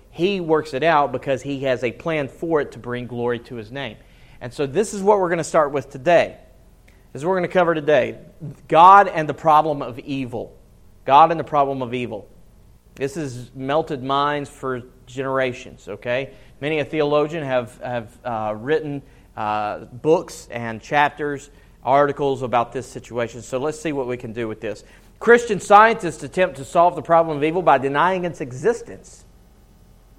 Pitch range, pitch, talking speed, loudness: 125-160 Hz, 140 Hz, 185 wpm, -20 LUFS